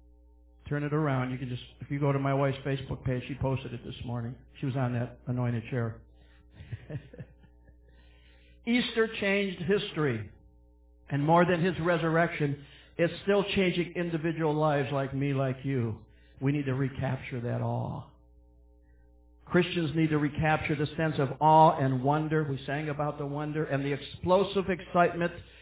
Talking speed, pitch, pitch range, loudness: 155 wpm, 140 Hz, 120-160 Hz, -29 LUFS